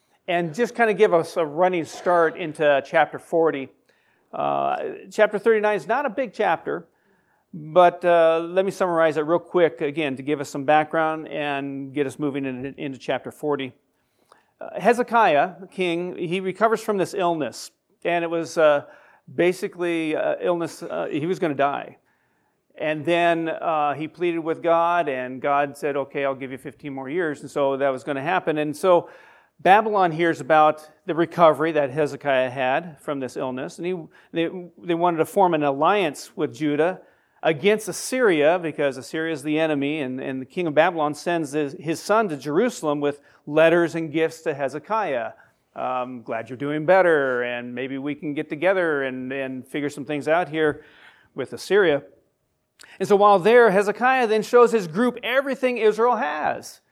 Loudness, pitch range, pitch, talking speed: -22 LUFS, 145-180 Hz, 160 Hz, 180 wpm